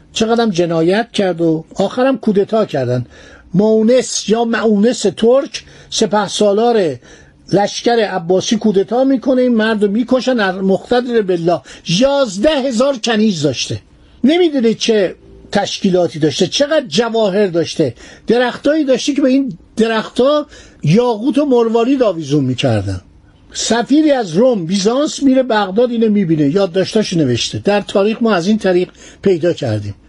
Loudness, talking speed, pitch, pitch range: -14 LUFS, 125 wpm, 215 Hz, 180-245 Hz